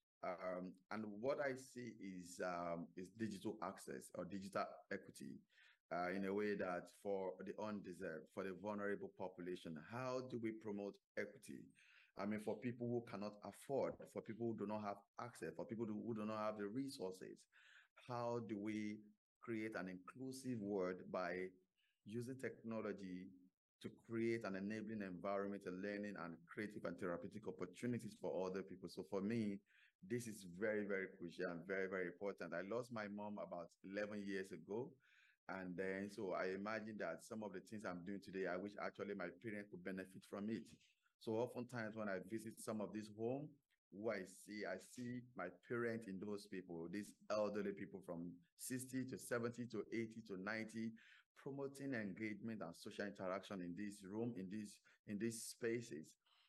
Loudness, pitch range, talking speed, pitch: -49 LUFS, 95-115 Hz, 175 wpm, 105 Hz